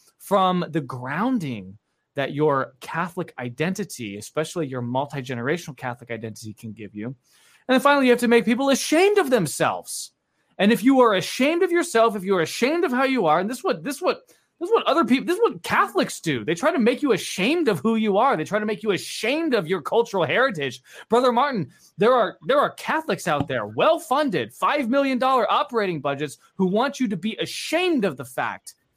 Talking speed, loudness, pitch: 215 wpm, -22 LUFS, 205 Hz